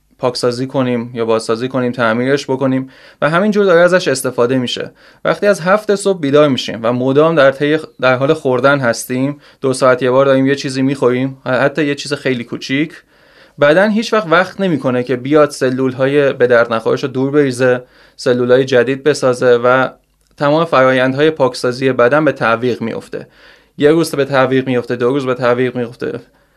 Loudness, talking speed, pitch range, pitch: -14 LUFS, 175 wpm, 125-145 Hz, 130 Hz